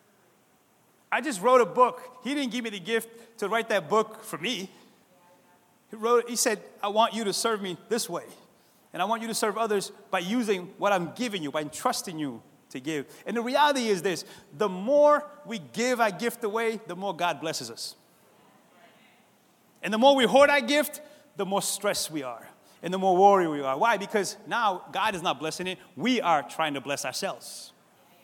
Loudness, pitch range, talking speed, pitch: -26 LUFS, 185-235 Hz, 205 wpm, 215 Hz